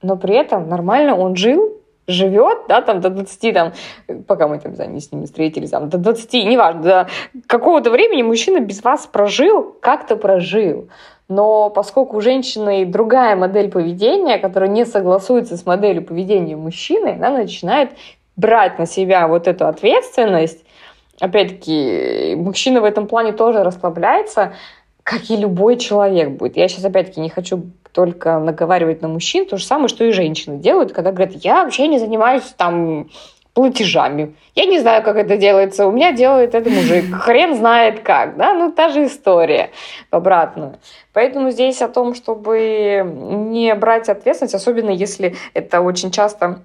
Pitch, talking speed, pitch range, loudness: 205 Hz, 155 wpm, 185-240 Hz, -15 LUFS